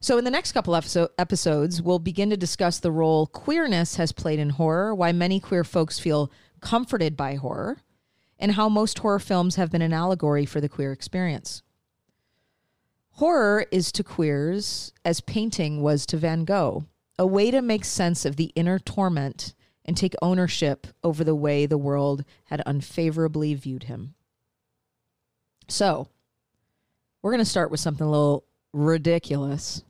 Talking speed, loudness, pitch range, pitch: 160 wpm, -24 LUFS, 150-185 Hz, 170 Hz